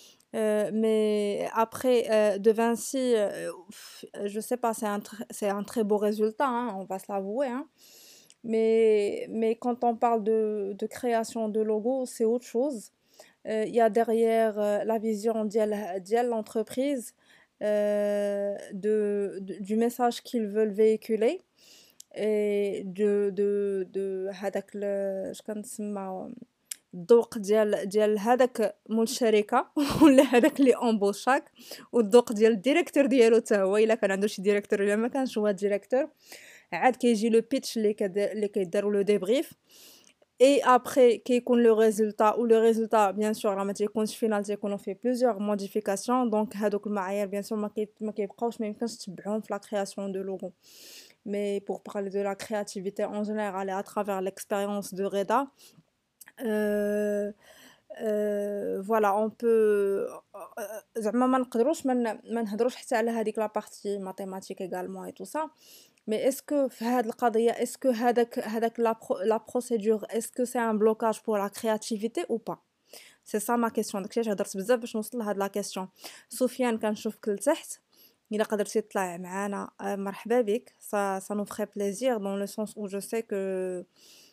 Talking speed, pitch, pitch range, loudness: 135 wpm, 215 Hz, 205-235 Hz, -27 LUFS